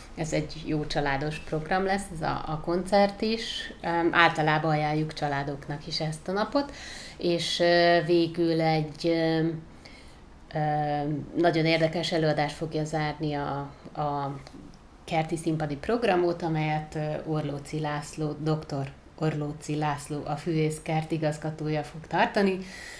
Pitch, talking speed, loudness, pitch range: 155 Hz, 110 wpm, -28 LUFS, 150-170 Hz